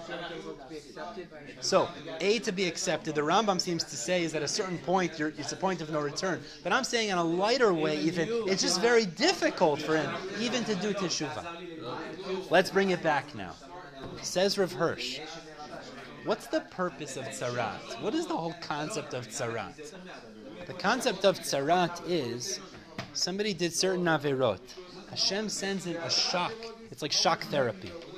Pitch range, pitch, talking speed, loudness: 155-195 Hz, 175 Hz, 165 wpm, -30 LUFS